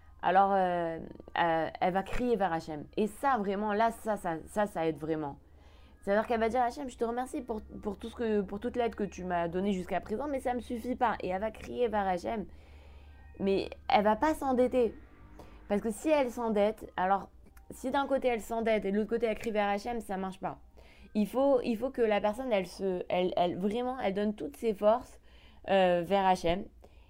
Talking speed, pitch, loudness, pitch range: 220 wpm, 205 Hz, -31 LUFS, 180-235 Hz